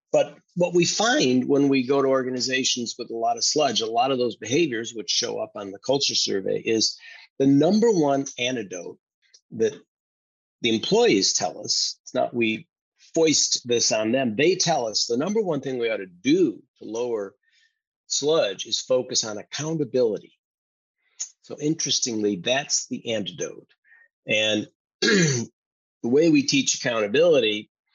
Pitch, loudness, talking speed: 140 Hz, -23 LUFS, 155 wpm